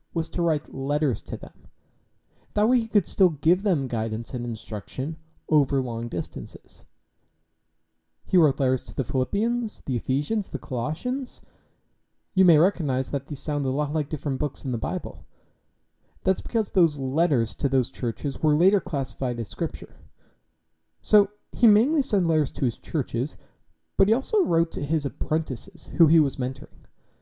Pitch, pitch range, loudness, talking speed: 145 Hz, 125-170 Hz, -25 LUFS, 165 wpm